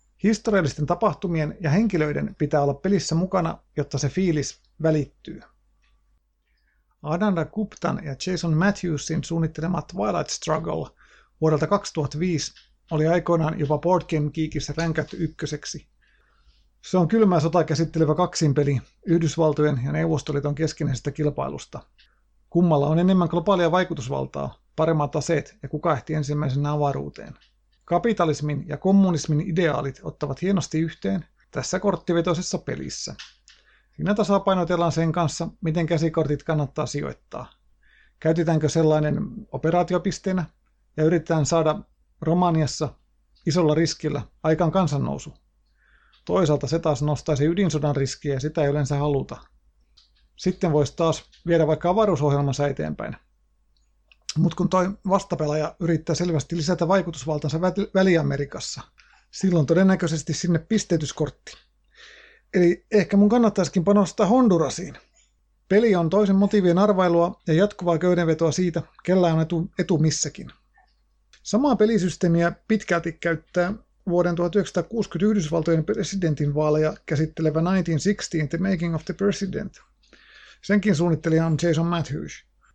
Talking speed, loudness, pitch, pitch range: 110 wpm, -23 LUFS, 165 Hz, 150-185 Hz